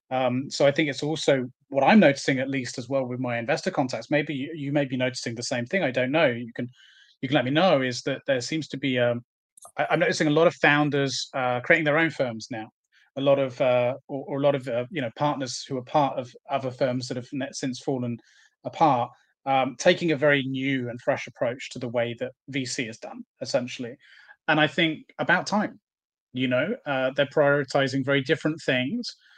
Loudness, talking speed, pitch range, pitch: -25 LUFS, 225 wpm, 125-150 Hz, 135 Hz